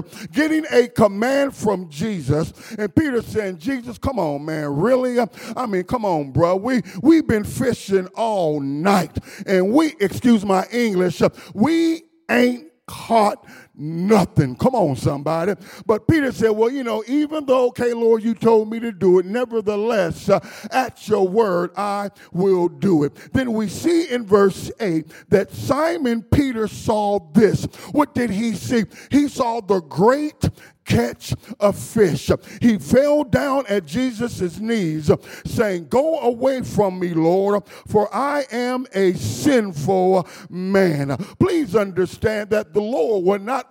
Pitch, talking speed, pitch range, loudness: 215 Hz, 150 wpm, 185-245 Hz, -20 LUFS